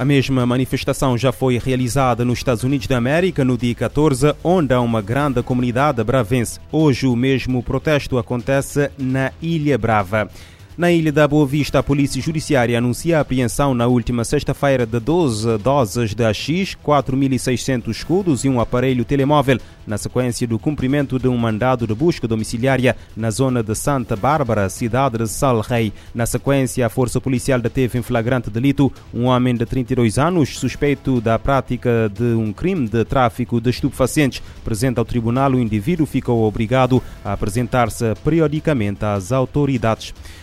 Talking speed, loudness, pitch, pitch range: 160 wpm, -18 LUFS, 125 Hz, 115-140 Hz